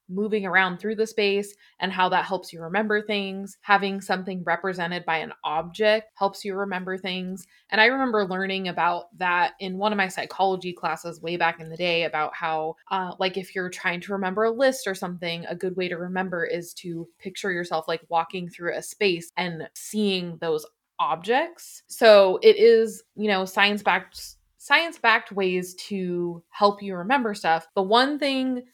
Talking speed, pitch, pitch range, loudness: 185 wpm, 190 Hz, 175-210 Hz, -24 LUFS